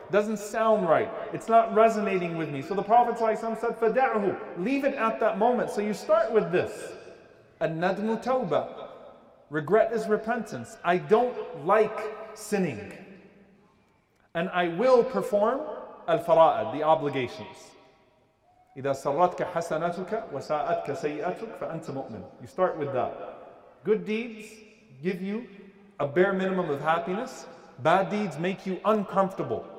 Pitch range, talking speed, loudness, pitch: 170-220 Hz, 125 wpm, -27 LUFS, 200 Hz